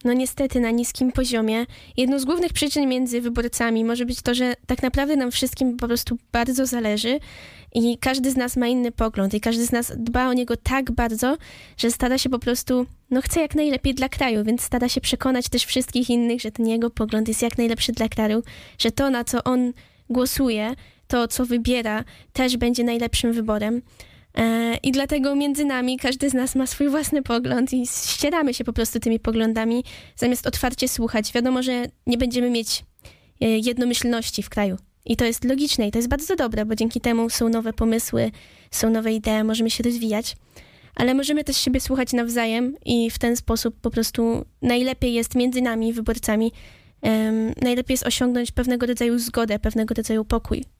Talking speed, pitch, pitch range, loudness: 185 wpm, 240 Hz, 230-255 Hz, -22 LUFS